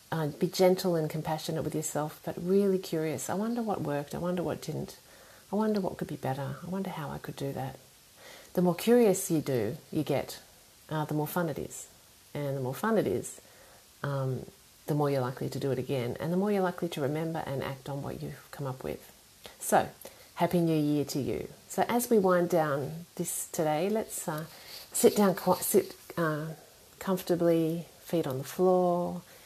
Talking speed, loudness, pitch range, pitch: 200 wpm, -31 LUFS, 145-180 Hz, 160 Hz